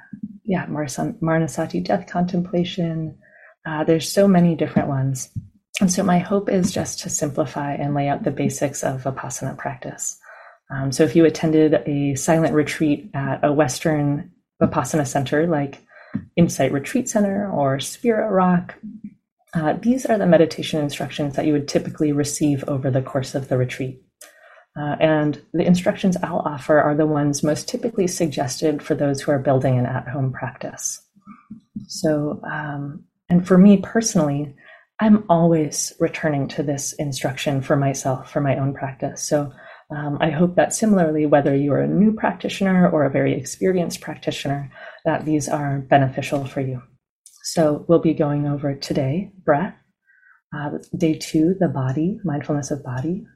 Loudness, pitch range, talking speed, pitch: -21 LUFS, 145-175 Hz, 155 wpm, 155 Hz